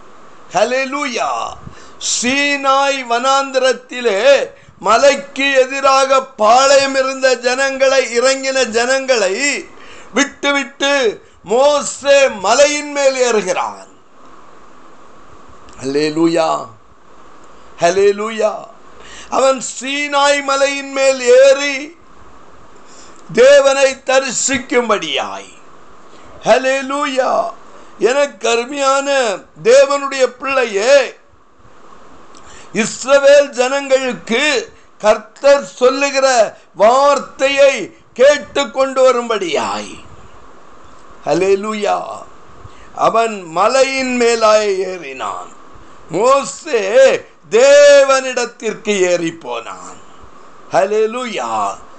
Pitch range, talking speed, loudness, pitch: 240-280 Hz, 50 wpm, -13 LUFS, 270 Hz